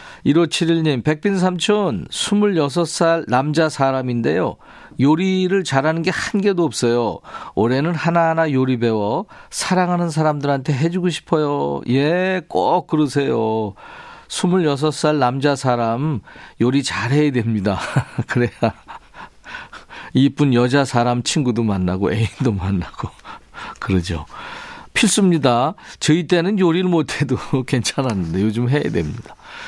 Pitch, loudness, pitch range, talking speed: 145 Hz, -18 LUFS, 120-175 Hz, 245 characters per minute